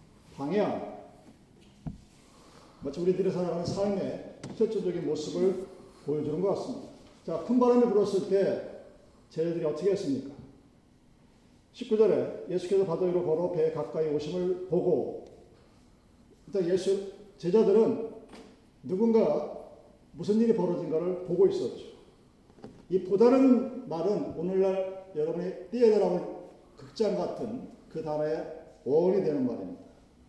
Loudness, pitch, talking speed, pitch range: -28 LUFS, 190 Hz, 260 characters per minute, 170-220 Hz